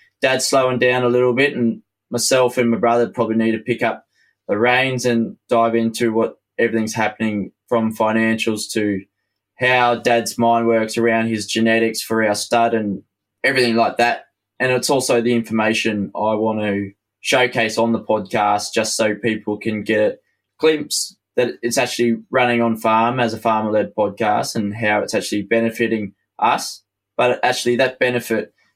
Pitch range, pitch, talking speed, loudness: 110-120 Hz, 115 Hz, 170 wpm, -18 LUFS